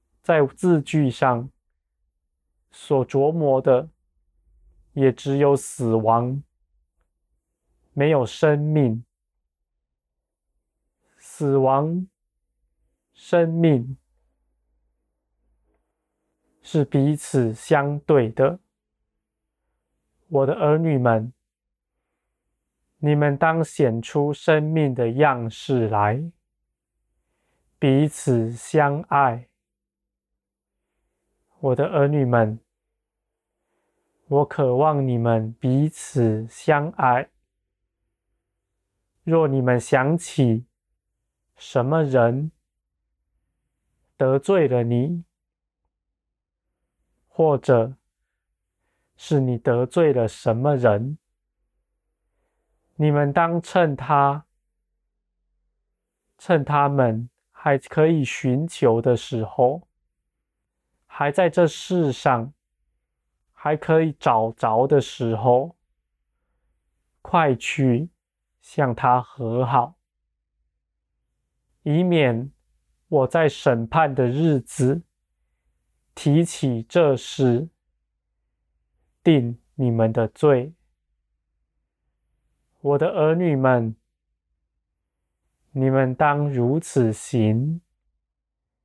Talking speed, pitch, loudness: 100 characters per minute, 120 Hz, -21 LUFS